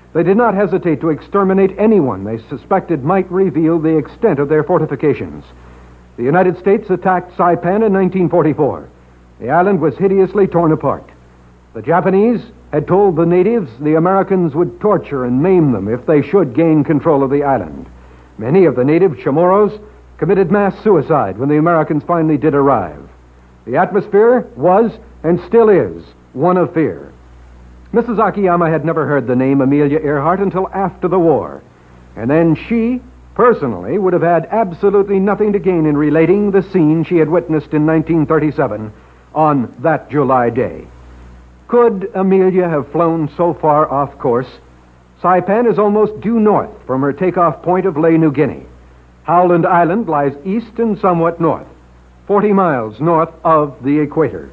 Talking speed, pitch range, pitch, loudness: 160 wpm, 140-190 Hz, 160 Hz, -14 LUFS